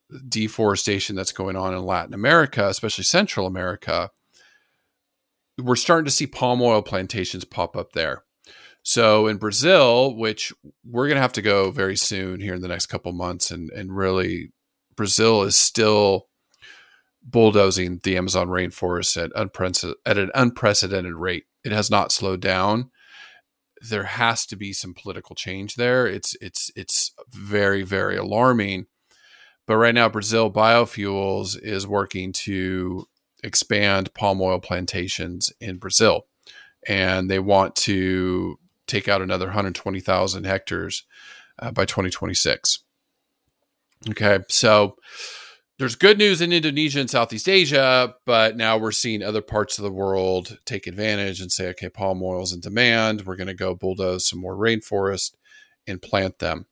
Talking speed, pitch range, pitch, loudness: 150 wpm, 95-115 Hz, 100 Hz, -21 LUFS